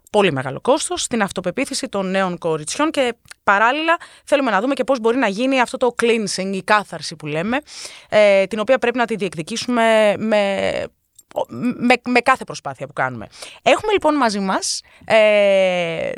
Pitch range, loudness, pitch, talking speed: 190-255 Hz, -18 LUFS, 220 Hz, 165 wpm